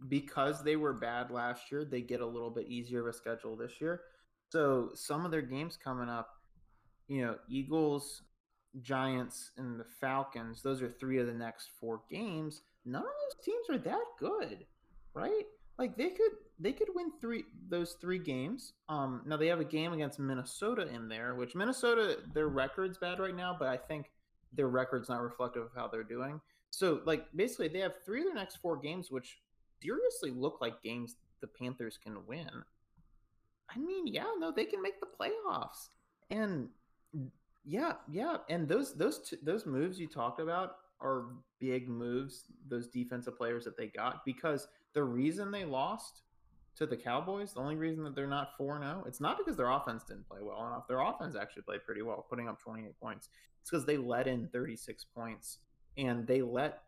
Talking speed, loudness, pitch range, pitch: 190 wpm, -38 LUFS, 120-175 Hz, 135 Hz